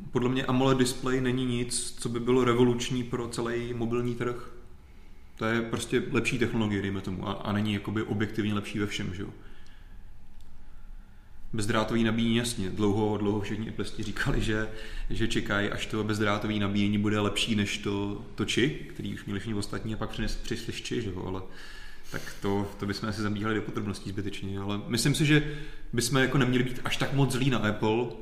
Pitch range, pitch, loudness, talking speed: 100-120 Hz, 110 Hz, -29 LUFS, 180 wpm